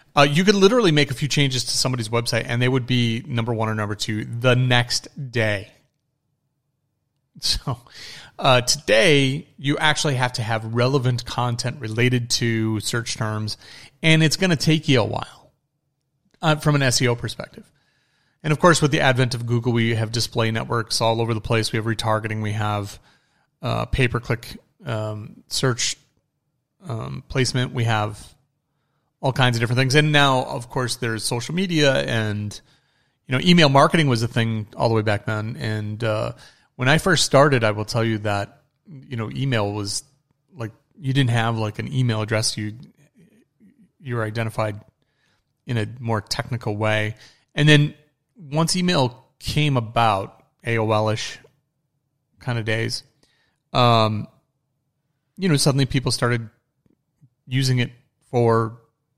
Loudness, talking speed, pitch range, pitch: -21 LUFS, 160 wpm, 115-145 Hz, 125 Hz